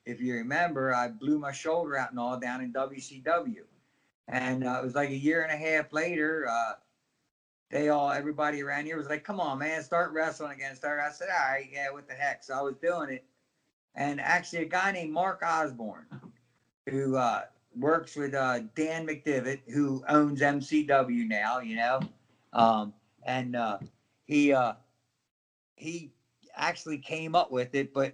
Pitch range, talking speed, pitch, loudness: 130-155 Hz, 180 wpm, 140 Hz, -30 LUFS